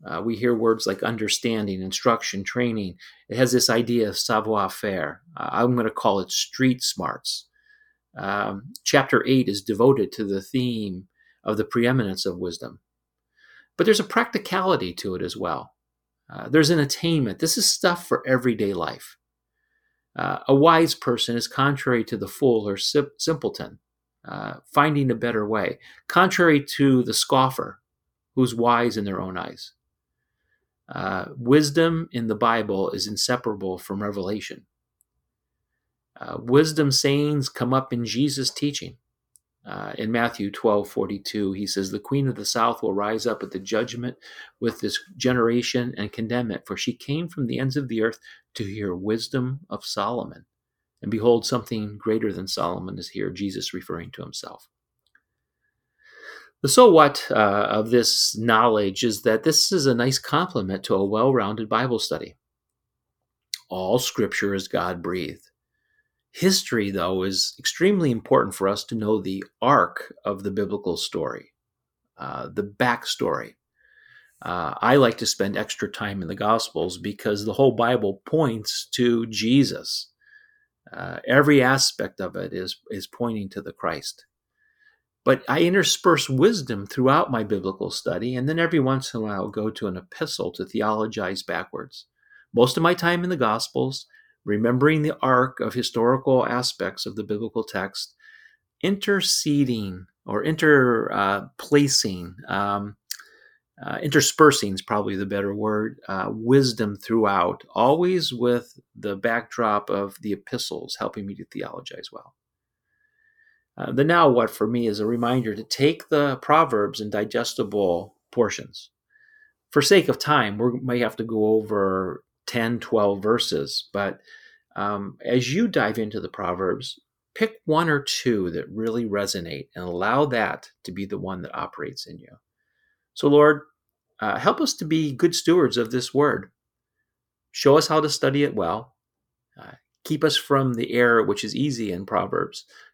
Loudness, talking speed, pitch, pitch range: -23 LUFS, 155 wpm, 120 Hz, 105-145 Hz